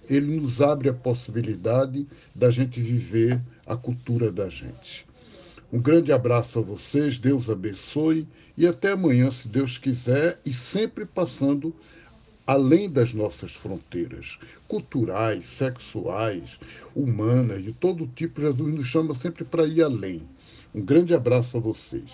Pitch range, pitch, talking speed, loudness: 115-155 Hz, 130 Hz, 135 wpm, -24 LUFS